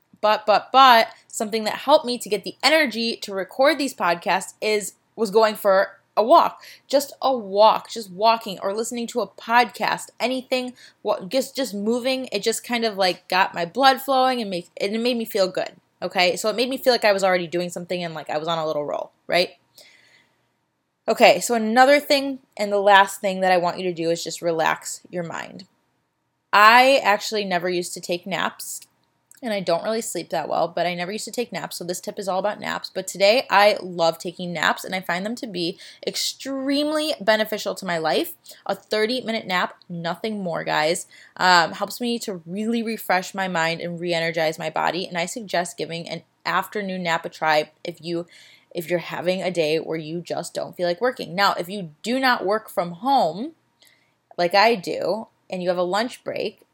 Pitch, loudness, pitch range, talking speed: 200 Hz, -22 LUFS, 175-230 Hz, 205 wpm